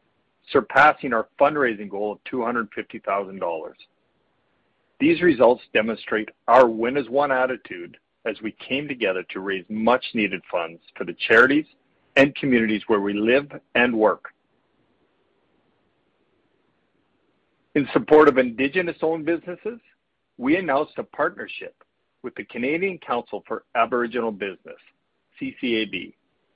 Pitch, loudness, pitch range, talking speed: 125 Hz, -22 LUFS, 110-165 Hz, 115 wpm